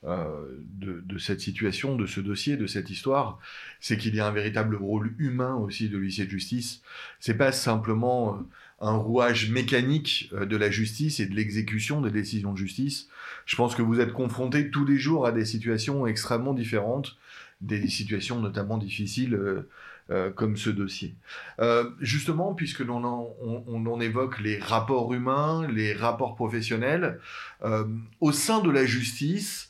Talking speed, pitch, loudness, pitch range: 170 wpm, 115 Hz, -28 LUFS, 105-130 Hz